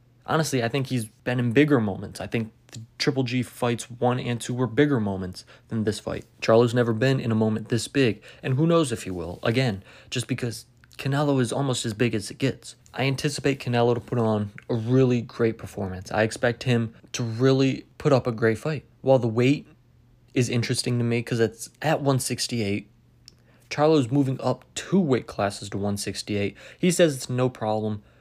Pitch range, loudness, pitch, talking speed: 115-135 Hz, -25 LUFS, 120 Hz, 195 wpm